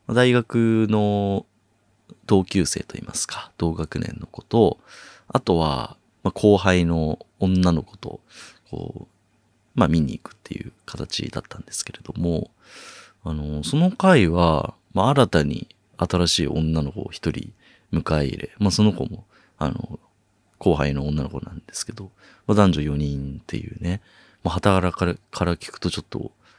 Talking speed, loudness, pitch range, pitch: 270 characters per minute, -22 LUFS, 80-105 Hz, 90 Hz